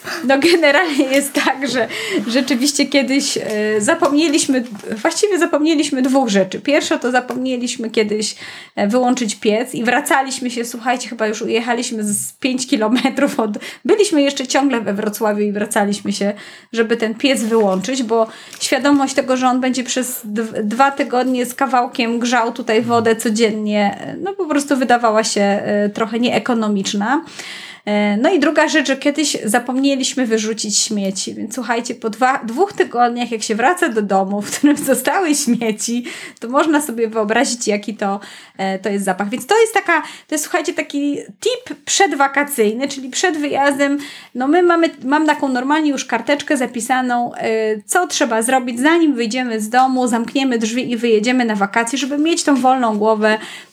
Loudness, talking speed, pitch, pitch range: -17 LUFS, 155 wpm, 250 Hz, 225-285 Hz